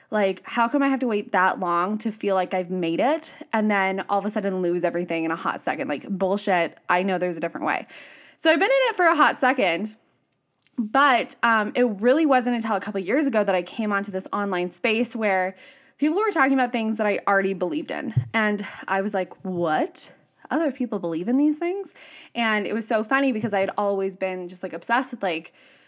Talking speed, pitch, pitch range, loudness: 230 wpm, 210 Hz, 190-255 Hz, -23 LUFS